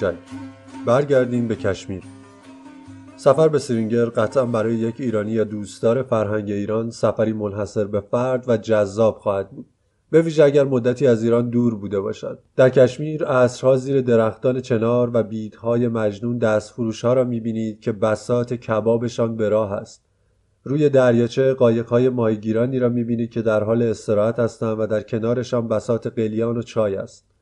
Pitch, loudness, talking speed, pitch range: 115 Hz, -20 LUFS, 150 wpm, 110-125 Hz